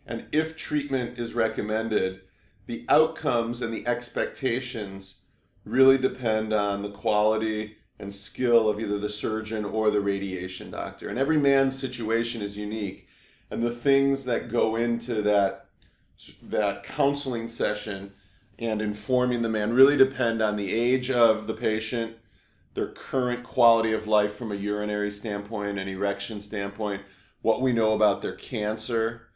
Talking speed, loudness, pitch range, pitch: 145 wpm, -26 LUFS, 105-120 Hz, 110 Hz